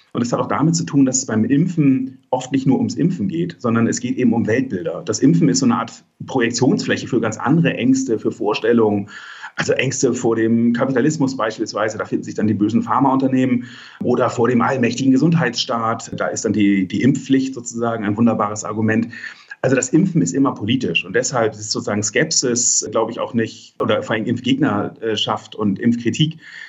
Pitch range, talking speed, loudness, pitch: 110-135 Hz, 190 wpm, -18 LUFS, 120 Hz